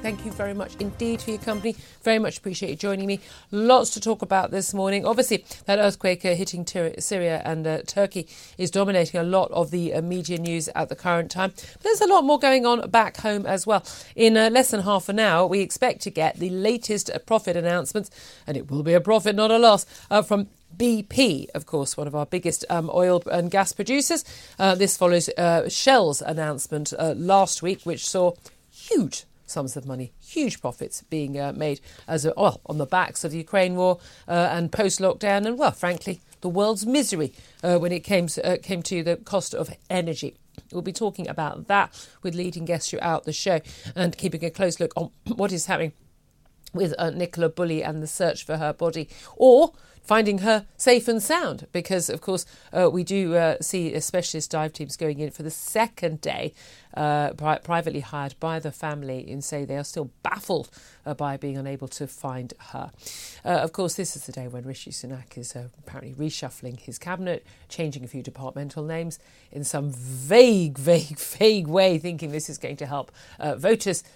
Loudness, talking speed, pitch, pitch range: -24 LUFS, 200 wpm, 175 Hz, 155-200 Hz